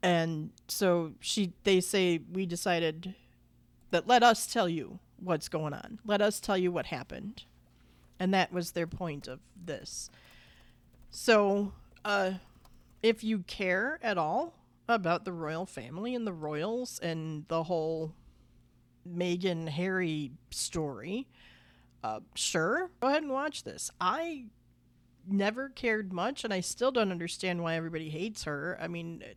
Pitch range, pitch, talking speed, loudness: 160-205 Hz, 180 Hz, 145 wpm, -32 LUFS